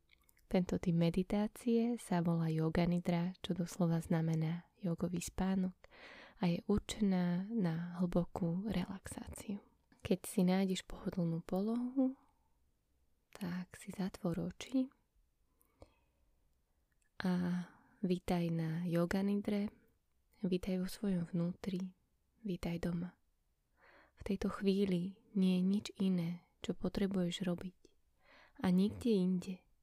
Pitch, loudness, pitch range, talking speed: 185 Hz, -38 LUFS, 175-200 Hz, 105 wpm